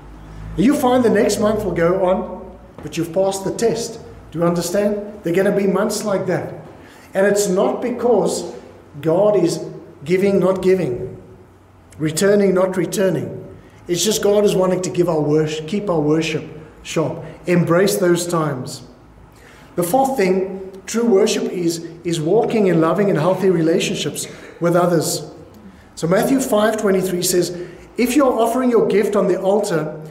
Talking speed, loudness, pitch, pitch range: 155 wpm, -18 LUFS, 185 Hz, 165-205 Hz